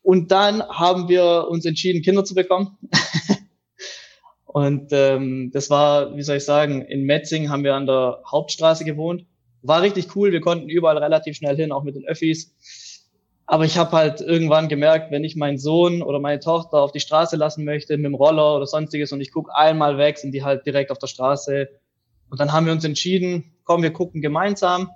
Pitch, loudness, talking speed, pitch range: 155 Hz, -19 LUFS, 200 wpm, 145-170 Hz